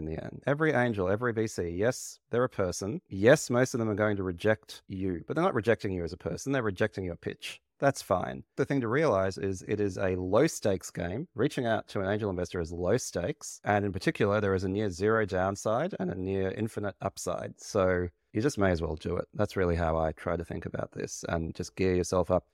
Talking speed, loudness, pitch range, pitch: 240 wpm, -30 LUFS, 90-105 Hz, 95 Hz